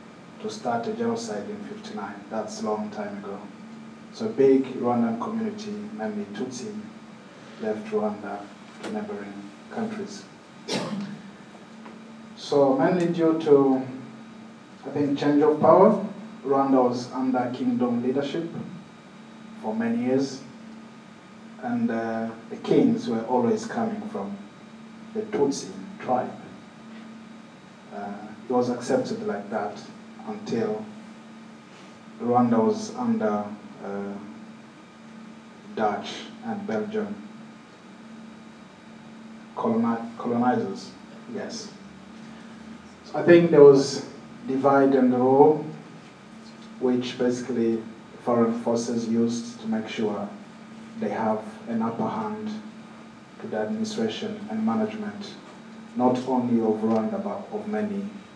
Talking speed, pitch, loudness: 105 wpm, 210 Hz, -25 LUFS